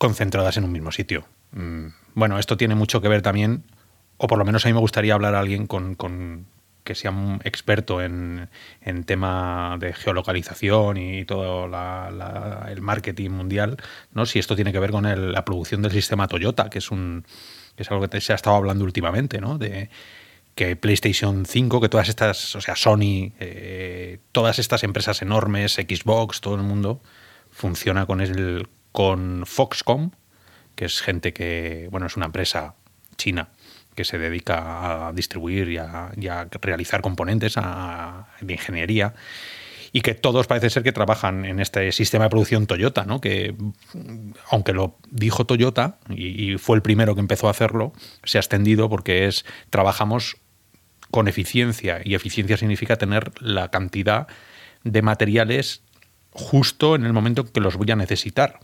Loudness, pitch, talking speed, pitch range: -22 LUFS, 100 Hz, 170 wpm, 95-110 Hz